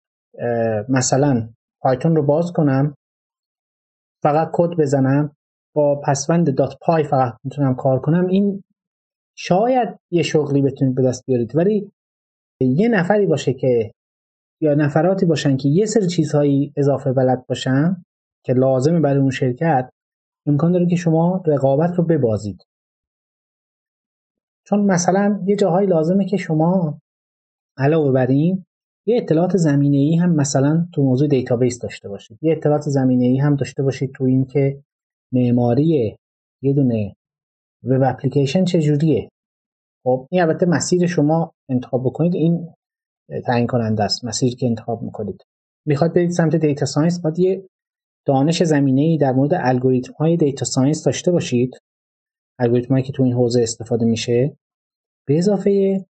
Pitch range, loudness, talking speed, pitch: 130-170 Hz, -18 LUFS, 140 wpm, 145 Hz